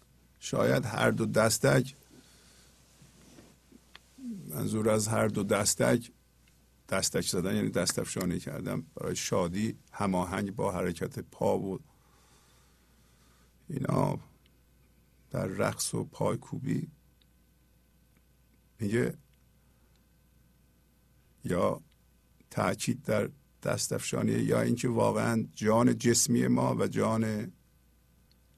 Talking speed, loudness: 85 wpm, -30 LUFS